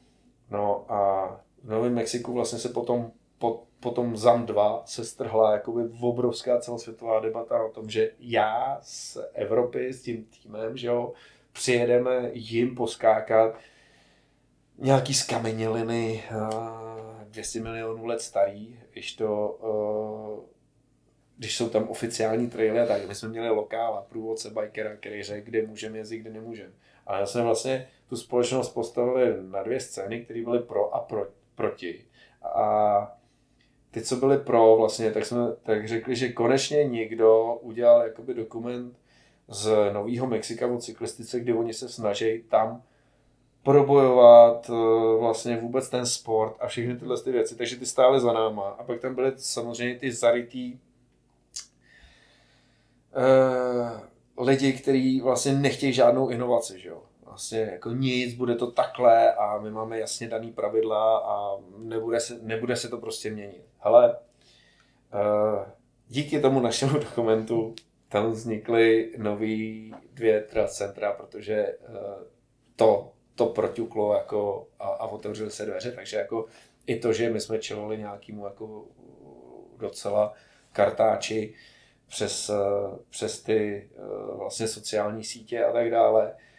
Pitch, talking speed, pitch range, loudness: 115 Hz, 130 wpm, 110-120 Hz, -25 LUFS